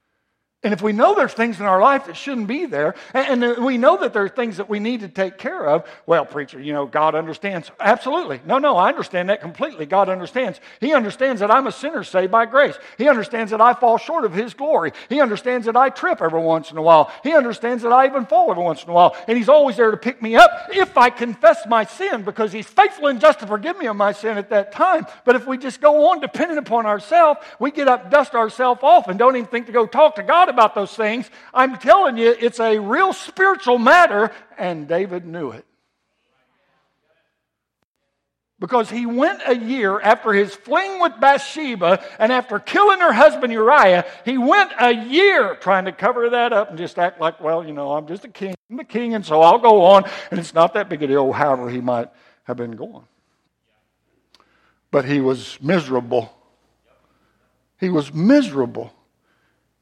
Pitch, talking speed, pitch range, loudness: 230 Hz, 210 wpm, 190-280 Hz, -17 LUFS